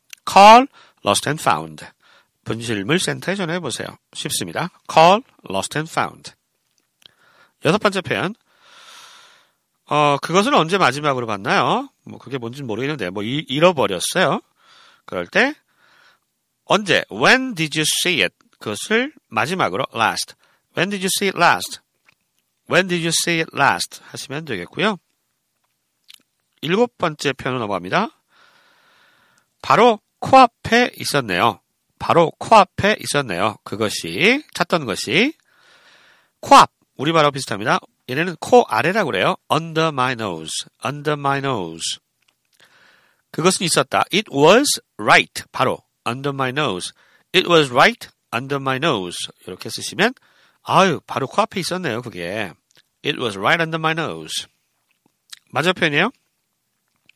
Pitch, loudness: 165 Hz, -18 LUFS